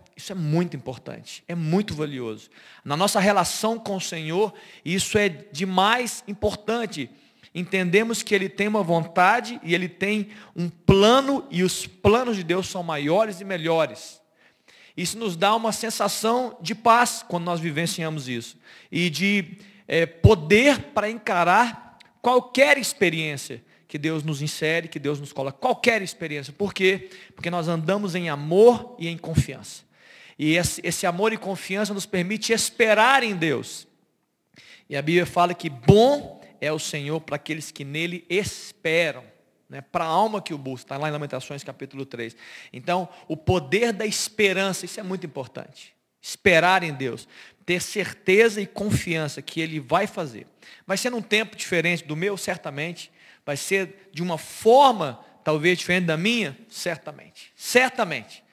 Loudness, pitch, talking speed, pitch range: -23 LUFS, 180 Hz, 155 wpm, 155-210 Hz